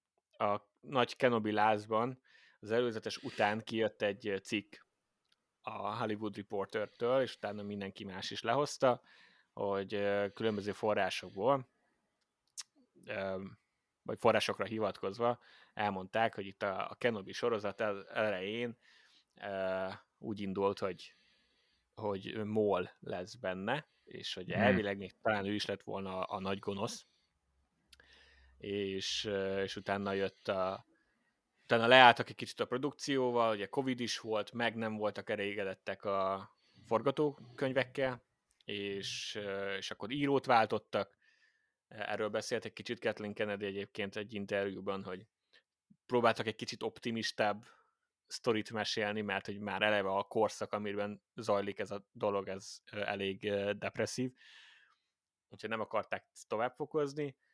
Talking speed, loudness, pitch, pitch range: 115 wpm, -36 LUFS, 105 Hz, 100-115 Hz